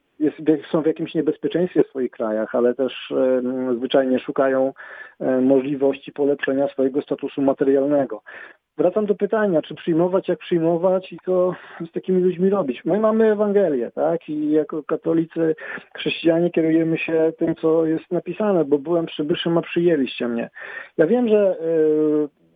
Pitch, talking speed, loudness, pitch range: 160 Hz, 150 wpm, -21 LUFS, 140-175 Hz